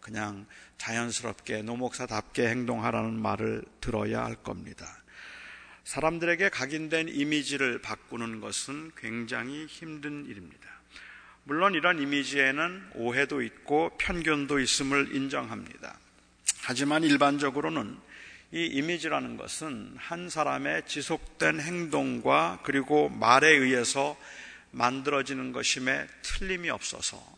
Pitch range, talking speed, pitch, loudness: 120-155 Hz, 275 characters per minute, 140 Hz, -28 LUFS